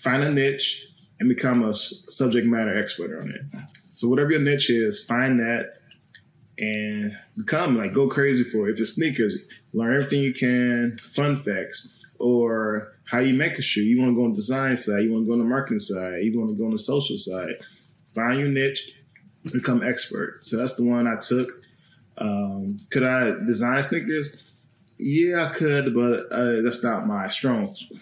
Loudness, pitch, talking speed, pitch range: -23 LUFS, 125 Hz, 185 wpm, 115-140 Hz